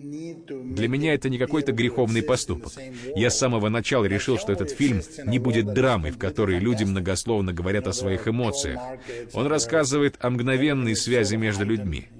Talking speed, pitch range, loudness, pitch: 160 wpm, 105-130 Hz, -24 LUFS, 120 Hz